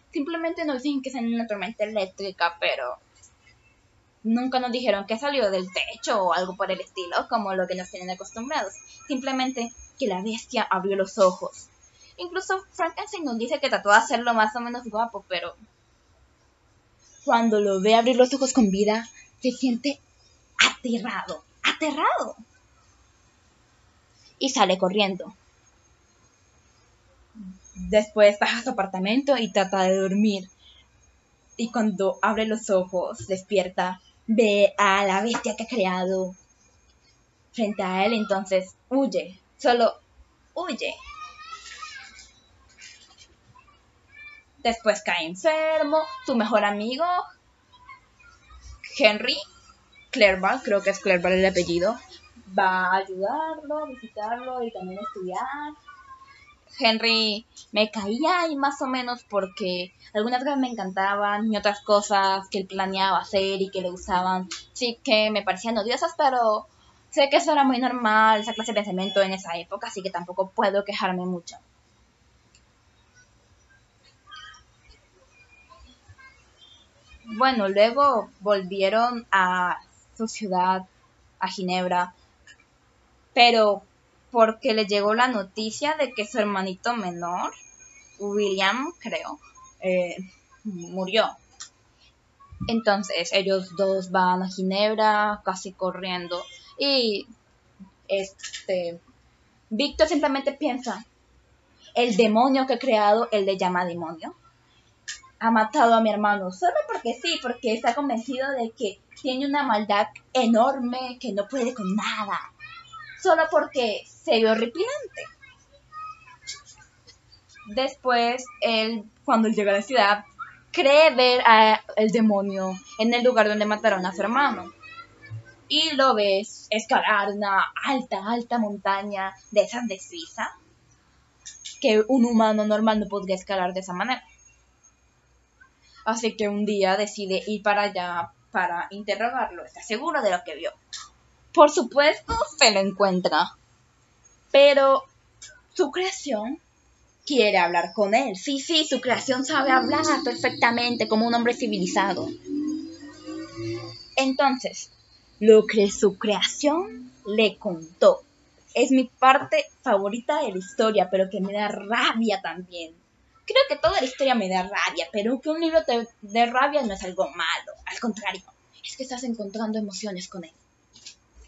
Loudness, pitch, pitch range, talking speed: -23 LUFS, 220 Hz, 195-265 Hz, 125 wpm